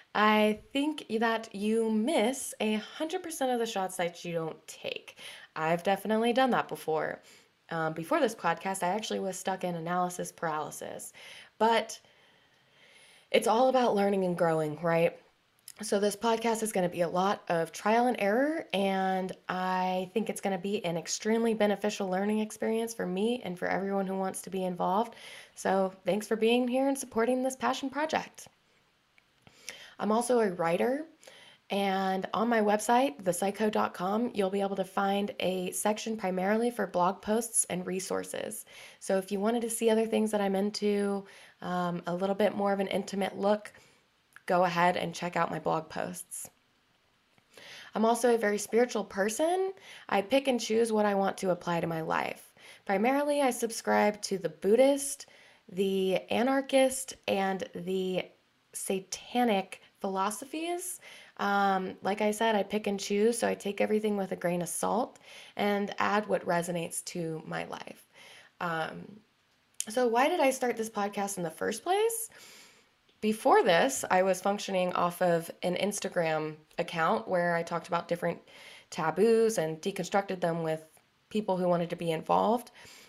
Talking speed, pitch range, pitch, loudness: 165 wpm, 180-230 Hz, 200 Hz, -30 LUFS